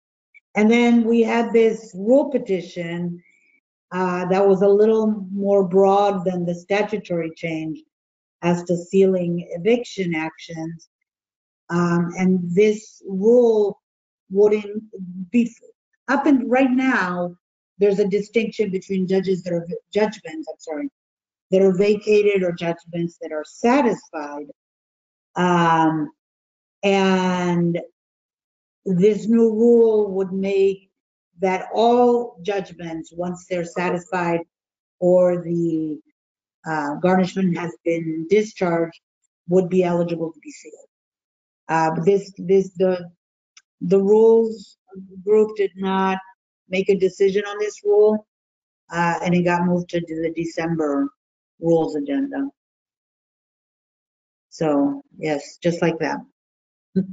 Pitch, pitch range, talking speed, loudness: 190 Hz, 170-215 Hz, 115 wpm, -20 LUFS